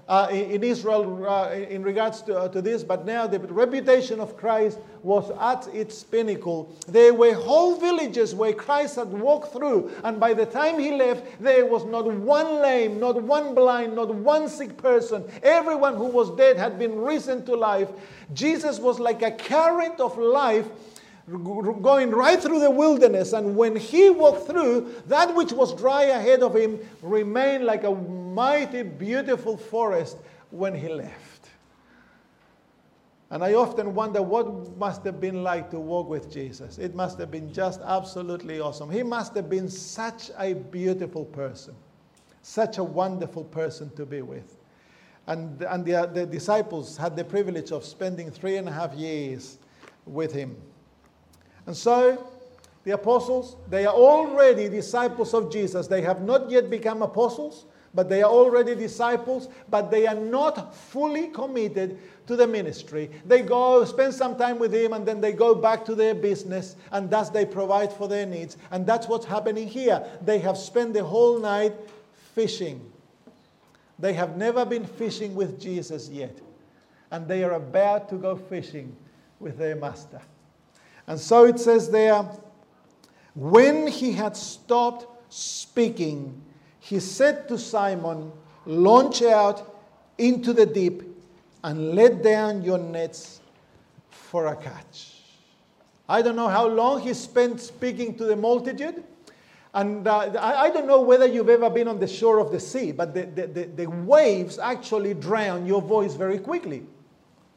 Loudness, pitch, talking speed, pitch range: -23 LUFS, 215 Hz, 160 wpm, 185-240 Hz